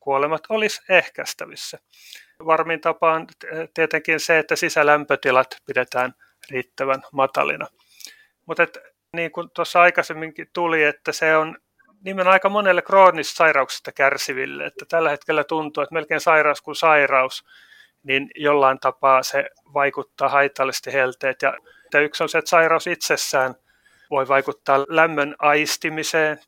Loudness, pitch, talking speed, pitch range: -19 LUFS, 155 Hz, 125 wpm, 140-165 Hz